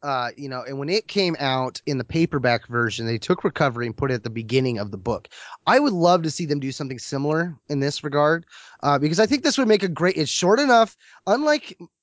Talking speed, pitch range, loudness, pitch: 240 wpm, 130-180 Hz, -22 LUFS, 145 Hz